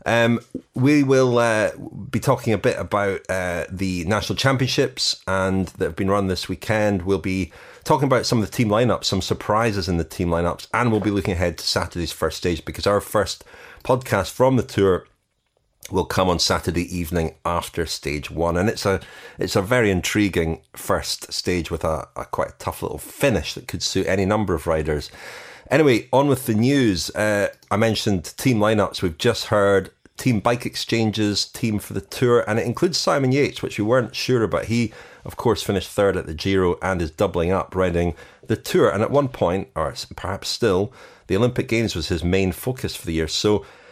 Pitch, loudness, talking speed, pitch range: 100 Hz, -21 LUFS, 200 wpm, 90-115 Hz